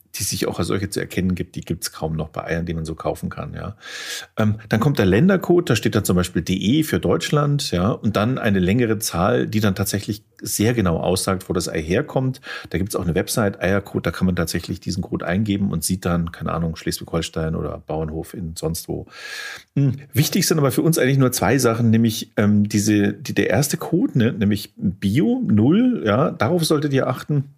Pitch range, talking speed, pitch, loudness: 90-135 Hz, 220 wpm, 105 Hz, -20 LUFS